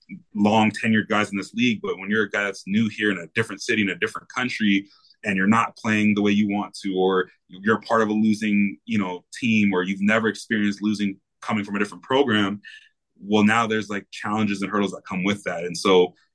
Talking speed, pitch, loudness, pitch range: 230 wpm, 105 Hz, -22 LUFS, 100-110 Hz